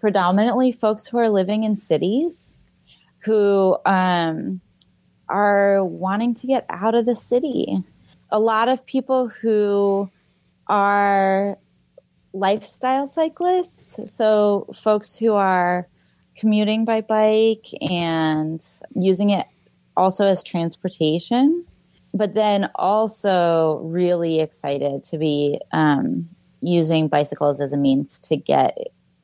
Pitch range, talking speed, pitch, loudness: 170-220 Hz, 110 wpm, 200 Hz, -20 LUFS